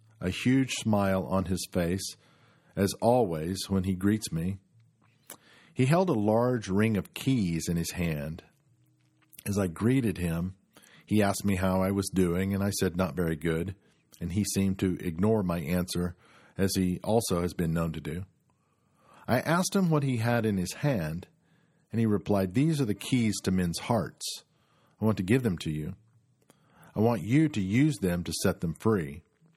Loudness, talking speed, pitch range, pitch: -29 LUFS, 185 wpm, 90-120 Hz, 100 Hz